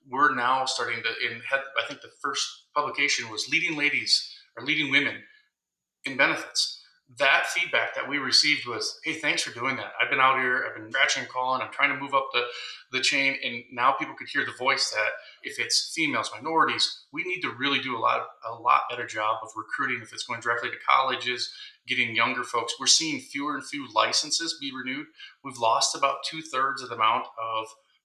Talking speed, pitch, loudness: 210 wpm, 150 Hz, -25 LUFS